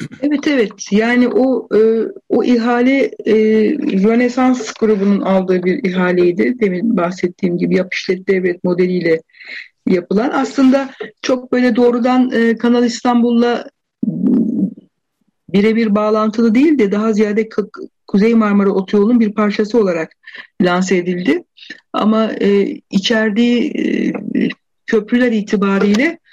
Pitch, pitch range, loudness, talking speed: 220 Hz, 200-245 Hz, -15 LUFS, 105 wpm